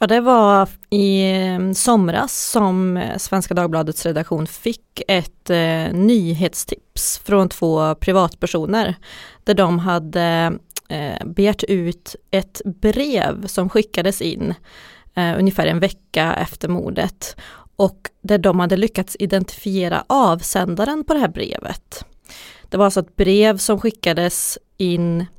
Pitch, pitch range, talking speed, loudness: 190 Hz, 175-205 Hz, 125 wpm, -18 LUFS